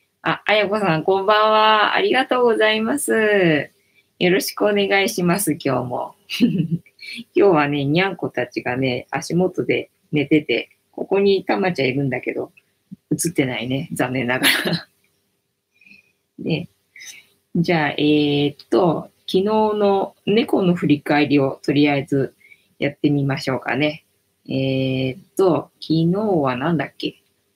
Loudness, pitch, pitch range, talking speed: -19 LUFS, 155 Hz, 135-195 Hz, 265 characters per minute